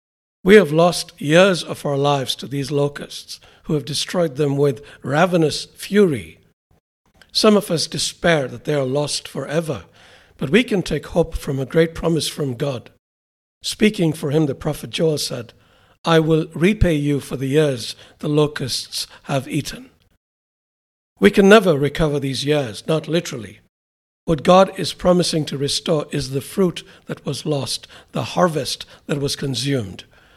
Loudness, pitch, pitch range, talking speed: -19 LUFS, 145 Hz, 130-165 Hz, 160 wpm